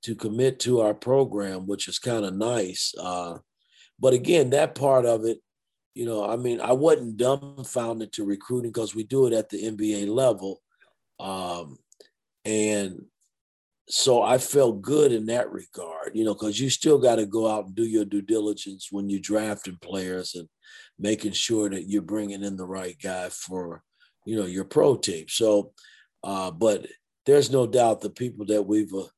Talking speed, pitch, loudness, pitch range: 180 wpm, 105 Hz, -25 LUFS, 100-120 Hz